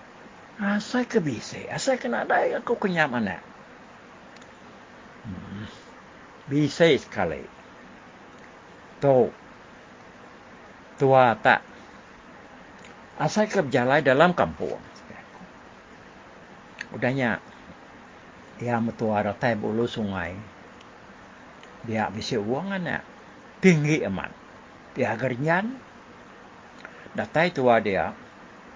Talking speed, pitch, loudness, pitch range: 75 wpm, 150 Hz, -24 LUFS, 115-195 Hz